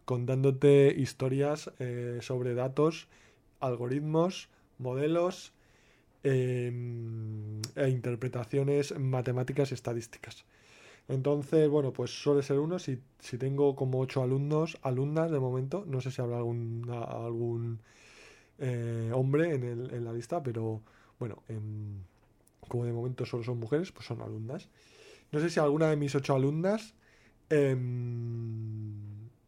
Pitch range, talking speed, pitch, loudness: 115-140 Hz, 130 wpm, 125 Hz, -32 LUFS